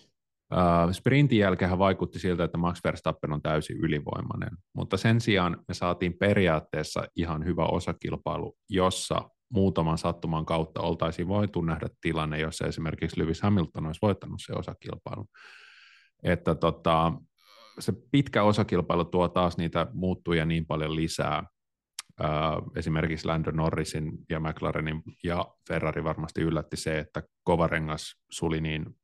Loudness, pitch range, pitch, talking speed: -28 LUFS, 80-90 Hz, 85 Hz, 125 wpm